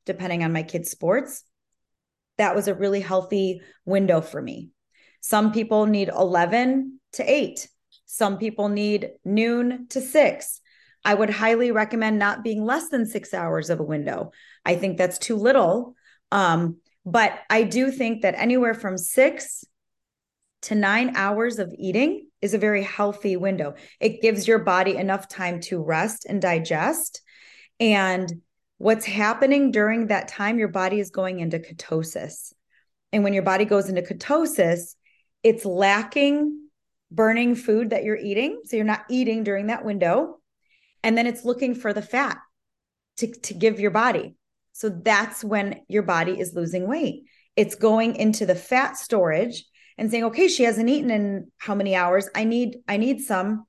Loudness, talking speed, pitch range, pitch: -23 LUFS, 165 wpm, 190-235 Hz, 210 Hz